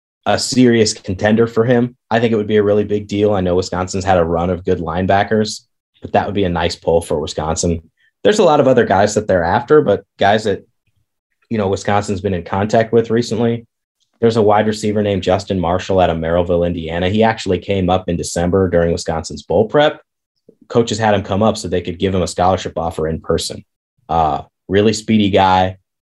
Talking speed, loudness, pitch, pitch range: 210 wpm, -16 LUFS, 100 Hz, 90-110 Hz